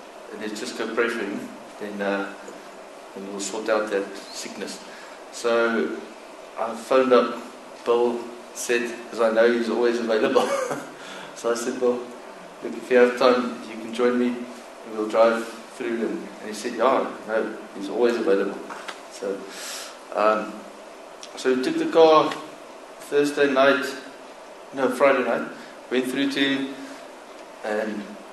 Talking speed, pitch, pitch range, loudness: 140 wpm, 120 Hz, 110-125 Hz, -23 LUFS